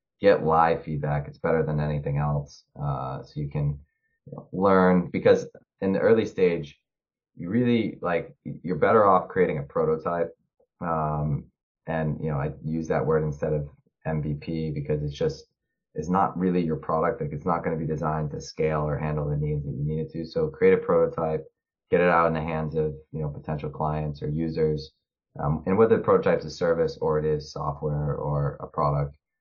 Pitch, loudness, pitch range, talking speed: 75 Hz, -26 LUFS, 75-80 Hz, 200 wpm